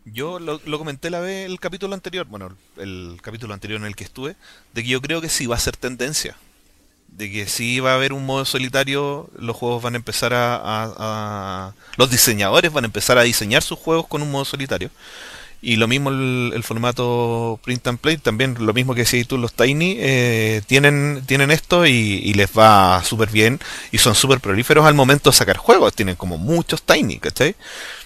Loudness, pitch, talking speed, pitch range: -17 LUFS, 125 Hz, 210 wpm, 110-145 Hz